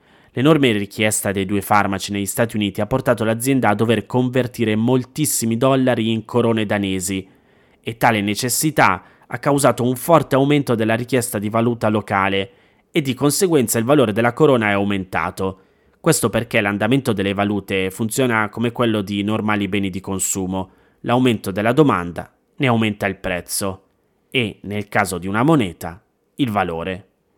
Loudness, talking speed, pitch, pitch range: -19 LUFS, 150 wpm, 110 Hz, 100-125 Hz